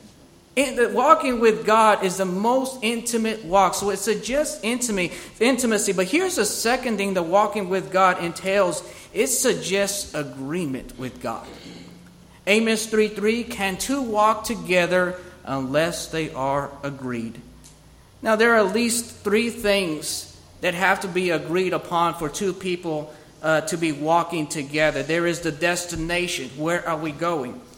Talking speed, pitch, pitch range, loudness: 145 wpm, 185 Hz, 160-220 Hz, -22 LUFS